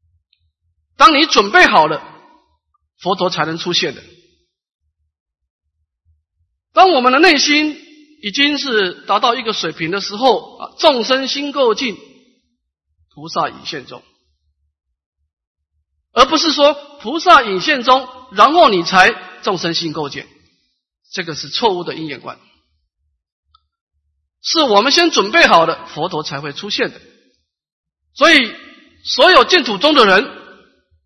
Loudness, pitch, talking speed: -13 LUFS, 170 Hz, 180 characters per minute